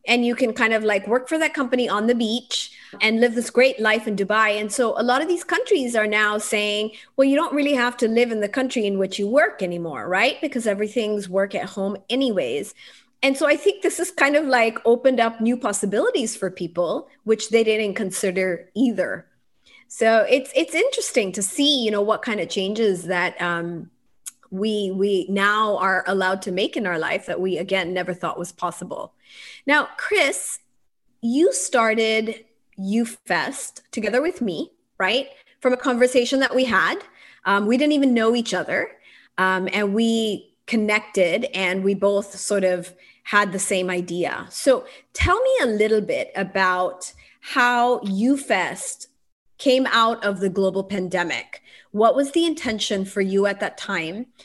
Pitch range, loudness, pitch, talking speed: 195-255 Hz, -21 LUFS, 220 Hz, 180 wpm